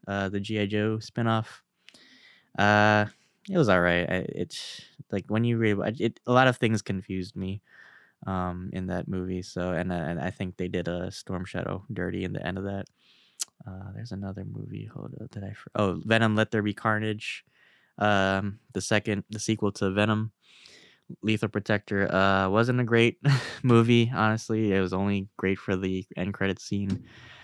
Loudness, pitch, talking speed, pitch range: -27 LUFS, 100 Hz, 175 wpm, 95-110 Hz